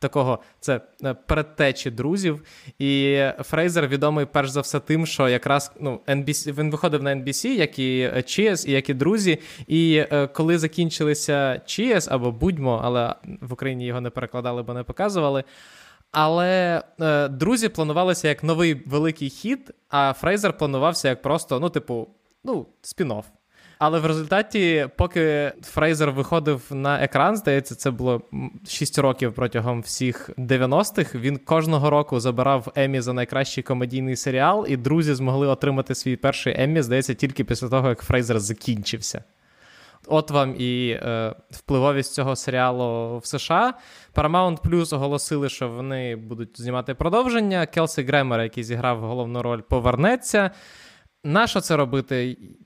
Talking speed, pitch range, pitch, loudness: 145 wpm, 125-160 Hz, 140 Hz, -22 LUFS